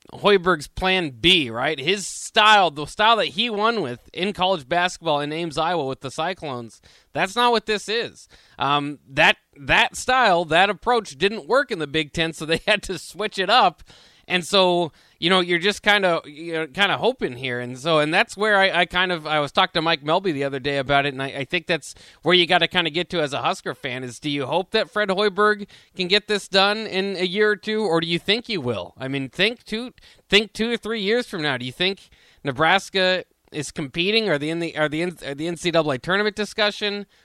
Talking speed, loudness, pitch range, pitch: 235 wpm, -21 LUFS, 150-205 Hz, 180 Hz